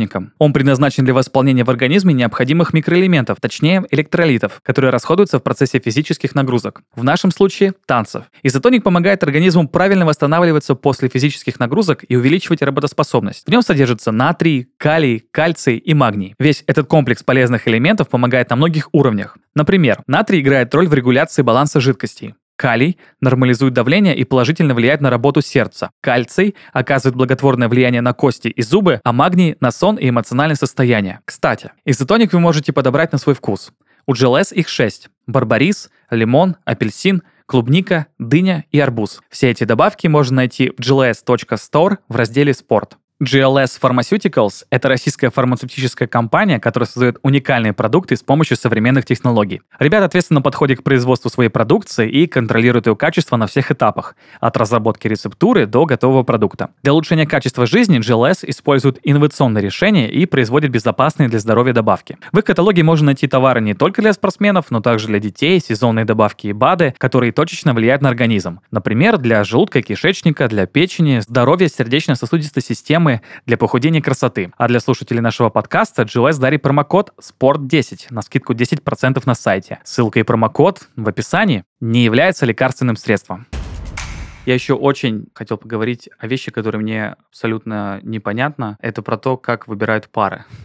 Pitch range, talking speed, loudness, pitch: 120-155 Hz, 155 wpm, -15 LUFS, 130 Hz